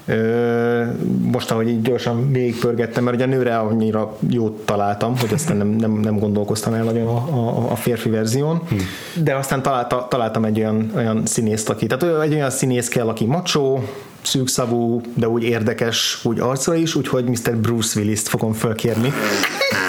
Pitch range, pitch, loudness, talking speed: 110-130 Hz, 120 Hz, -19 LUFS, 165 wpm